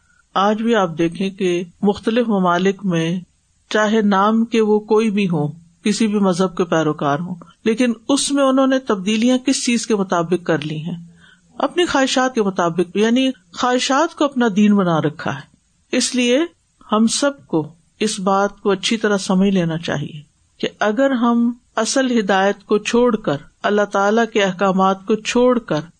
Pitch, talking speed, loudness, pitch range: 210 Hz, 170 wpm, -18 LUFS, 180-240 Hz